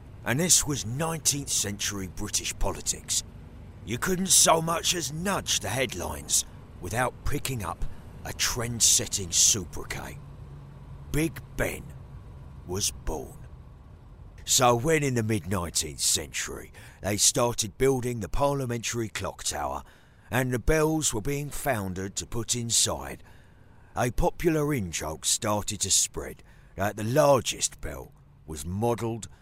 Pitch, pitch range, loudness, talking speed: 110 Hz, 95-130 Hz, -26 LUFS, 125 wpm